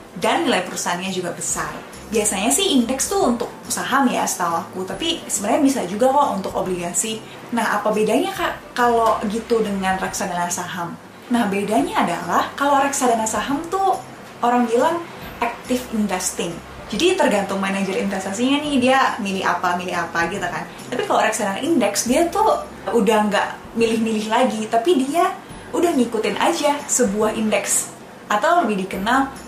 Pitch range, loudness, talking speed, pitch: 195-270 Hz, -20 LUFS, 150 wpm, 225 Hz